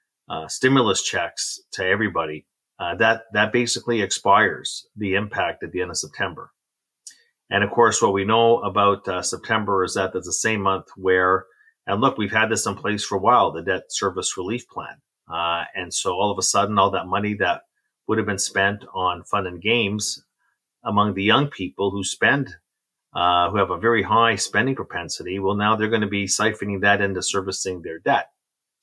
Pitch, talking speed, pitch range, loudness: 100 Hz, 195 wpm, 95-110 Hz, -21 LUFS